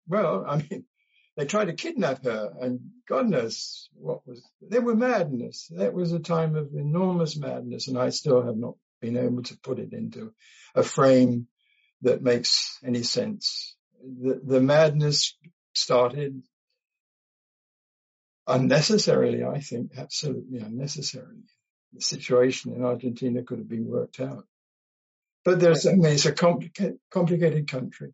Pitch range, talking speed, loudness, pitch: 125-185 Hz, 145 wpm, -25 LUFS, 150 Hz